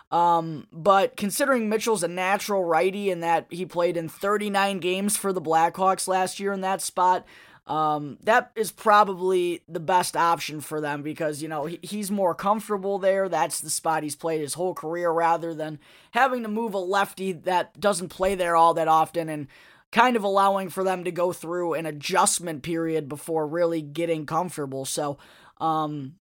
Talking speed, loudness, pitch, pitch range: 180 wpm, -24 LUFS, 175 Hz, 160-195 Hz